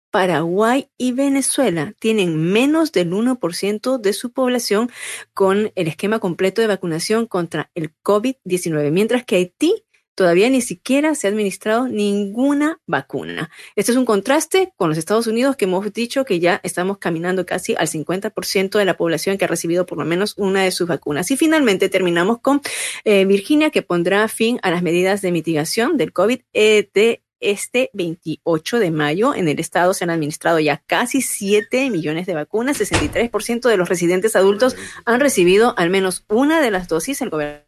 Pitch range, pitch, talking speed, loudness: 180-250 Hz, 200 Hz, 175 wpm, -18 LUFS